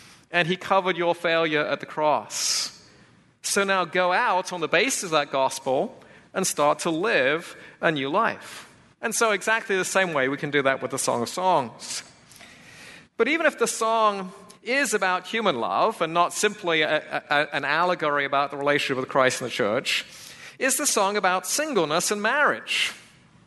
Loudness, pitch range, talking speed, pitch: -23 LUFS, 150-210 Hz, 180 wpm, 180 Hz